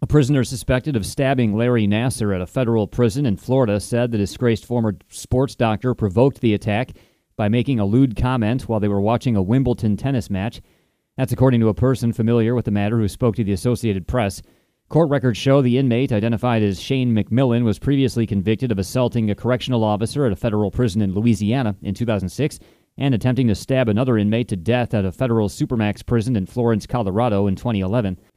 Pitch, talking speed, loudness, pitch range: 115 Hz, 195 wpm, -20 LUFS, 105-125 Hz